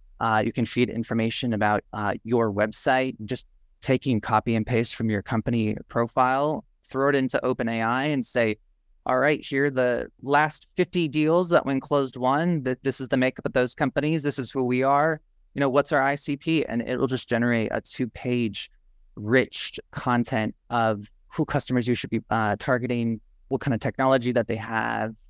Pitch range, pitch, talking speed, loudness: 115-140 Hz, 125 Hz, 185 wpm, -25 LUFS